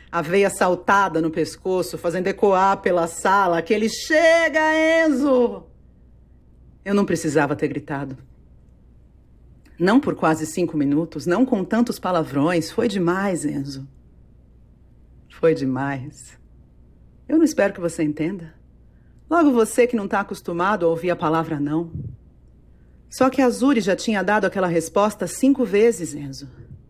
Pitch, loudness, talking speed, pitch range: 170 Hz, -20 LUFS, 135 wpm, 135-205 Hz